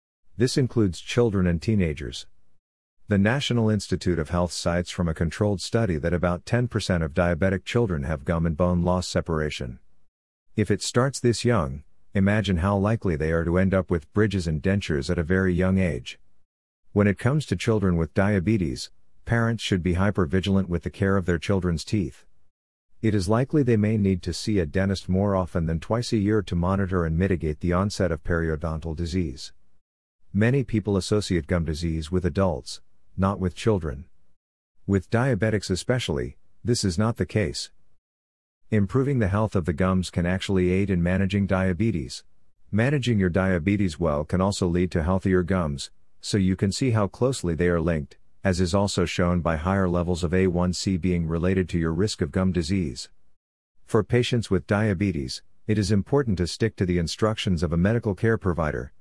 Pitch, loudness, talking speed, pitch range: 95 Hz, -24 LUFS, 180 wpm, 85-105 Hz